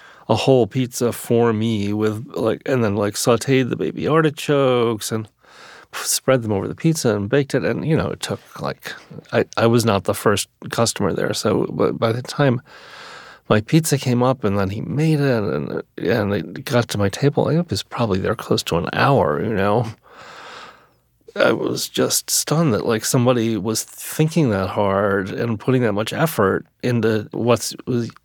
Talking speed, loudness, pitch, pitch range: 185 wpm, -20 LUFS, 120 Hz, 110-135 Hz